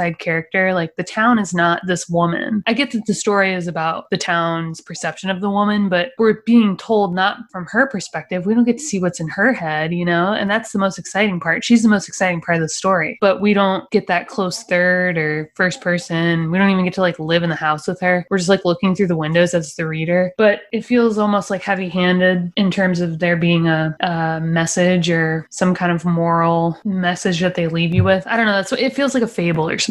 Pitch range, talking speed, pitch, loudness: 170-205 Hz, 250 wpm, 180 Hz, -17 LUFS